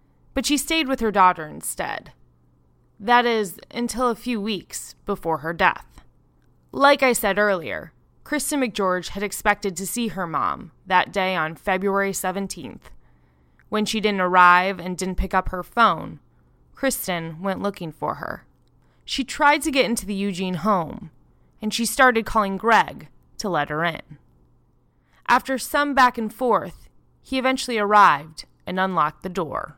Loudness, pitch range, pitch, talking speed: -21 LUFS, 180-235 Hz, 200 Hz, 155 wpm